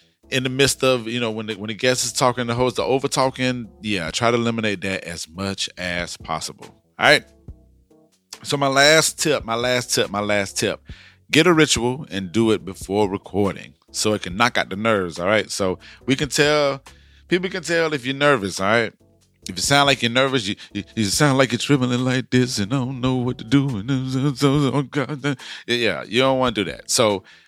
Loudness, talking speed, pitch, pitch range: -20 LUFS, 215 wpm, 120 Hz, 100-135 Hz